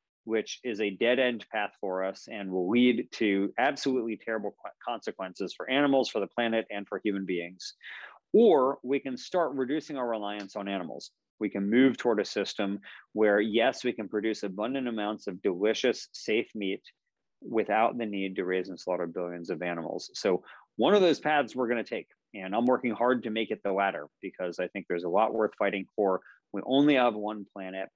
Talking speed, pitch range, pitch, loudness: 195 wpm, 100-125 Hz, 110 Hz, -29 LUFS